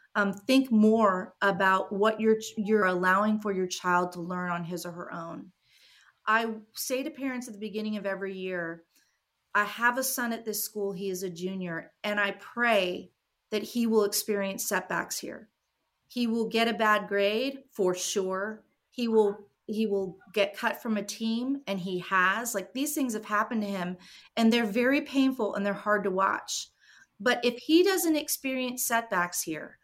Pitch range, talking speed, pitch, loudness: 190-235 Hz, 185 wpm, 210 Hz, -28 LUFS